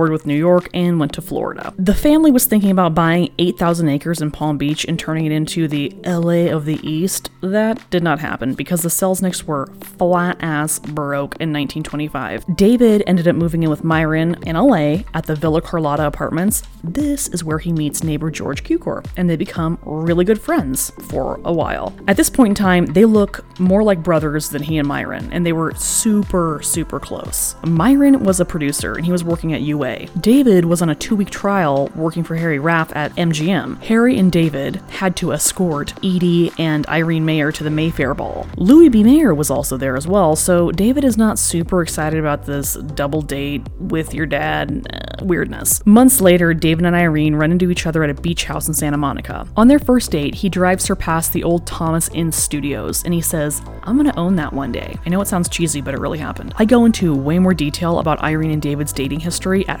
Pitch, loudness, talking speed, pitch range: 165 Hz, -16 LUFS, 210 wpm, 150-185 Hz